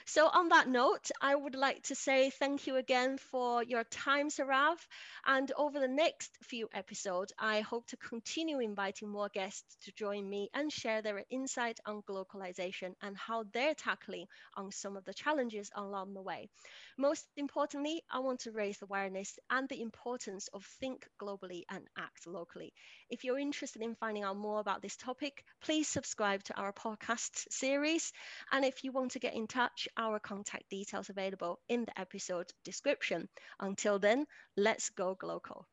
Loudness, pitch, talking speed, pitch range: -37 LUFS, 230 Hz, 175 wpm, 200-270 Hz